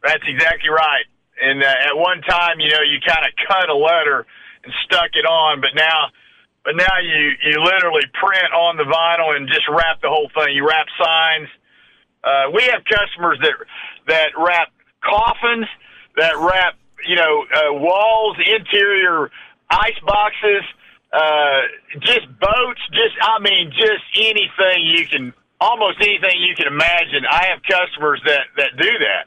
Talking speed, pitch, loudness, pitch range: 160 wpm, 175 Hz, -15 LUFS, 155-210 Hz